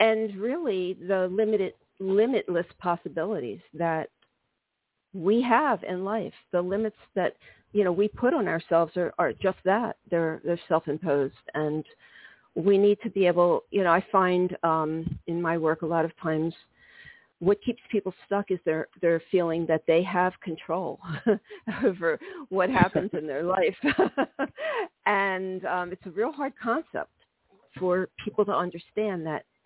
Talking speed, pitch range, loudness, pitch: 145 wpm, 165-210 Hz, -27 LUFS, 185 Hz